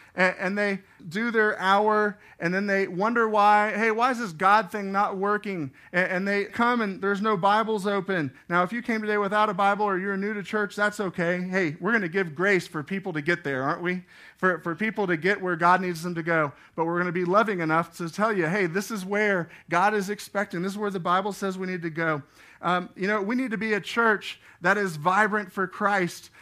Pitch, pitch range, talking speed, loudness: 195 Hz, 180-210 Hz, 240 wpm, -25 LUFS